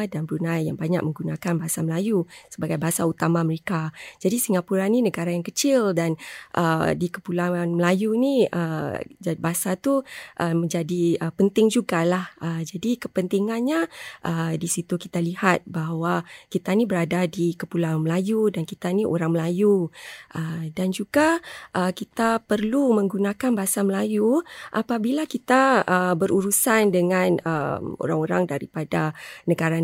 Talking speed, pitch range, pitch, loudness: 140 wpm, 165-210 Hz, 180 Hz, -23 LUFS